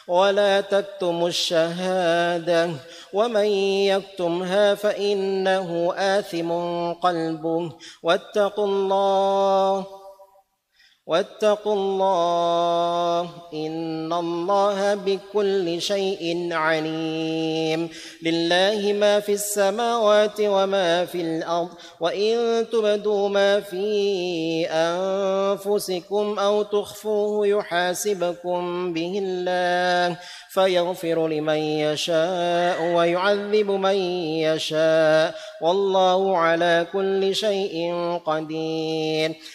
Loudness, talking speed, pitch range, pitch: -22 LUFS, 70 wpm, 170-200 Hz, 180 Hz